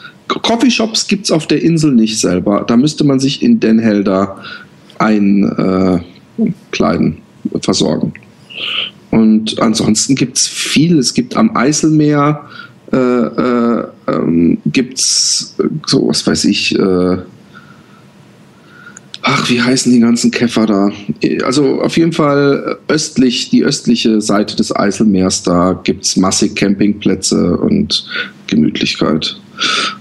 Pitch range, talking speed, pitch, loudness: 100-140 Hz, 120 wpm, 110 Hz, -12 LUFS